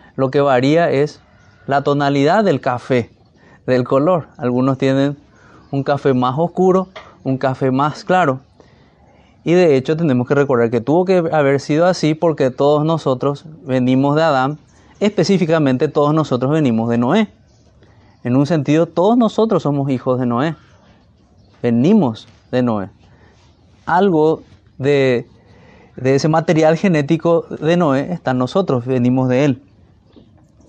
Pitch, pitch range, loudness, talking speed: 140 Hz, 125-160 Hz, -16 LUFS, 135 wpm